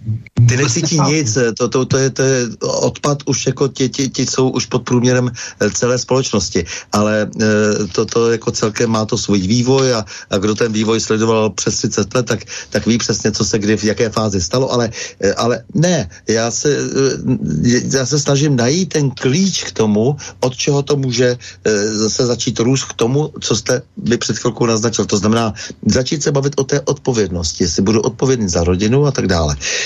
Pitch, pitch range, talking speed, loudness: 120 Hz, 110-135 Hz, 190 wpm, -15 LUFS